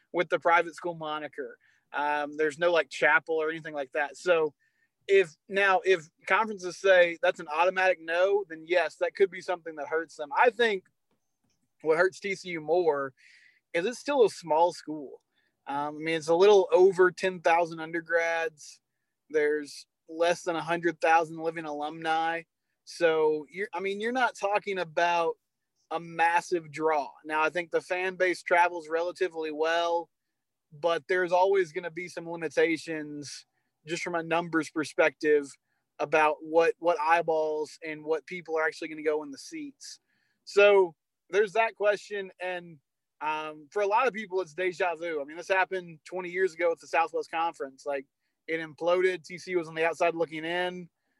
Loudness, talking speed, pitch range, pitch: -28 LUFS, 170 wpm, 155-185 Hz, 170 Hz